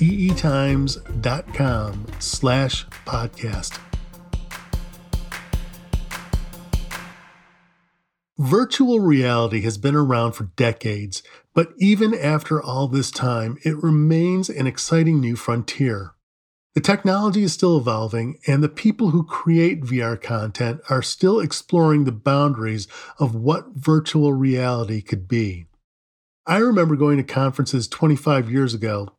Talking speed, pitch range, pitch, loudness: 105 wpm, 115-165 Hz, 140 Hz, -20 LUFS